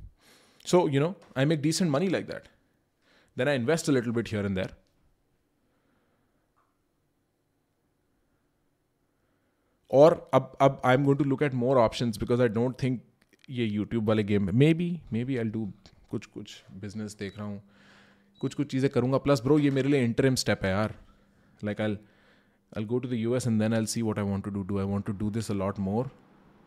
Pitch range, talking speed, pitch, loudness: 105-135 Hz, 180 wpm, 115 Hz, -27 LUFS